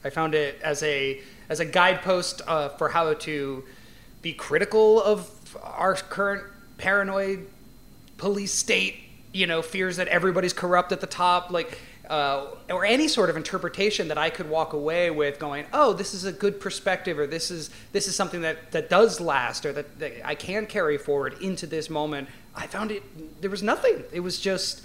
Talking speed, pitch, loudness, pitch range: 190 wpm, 180 Hz, -25 LUFS, 155-195 Hz